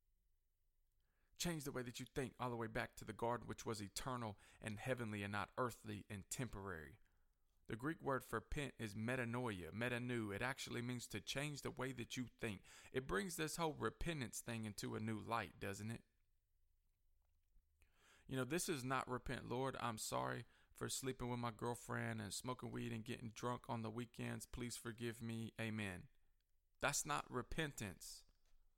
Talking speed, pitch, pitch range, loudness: 175 wpm, 115 Hz, 95-125 Hz, -47 LUFS